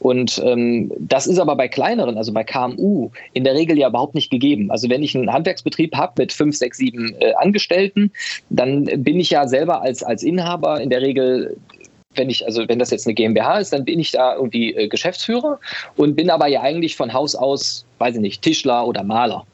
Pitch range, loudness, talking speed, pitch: 120-165 Hz, -18 LUFS, 215 wpm, 135 Hz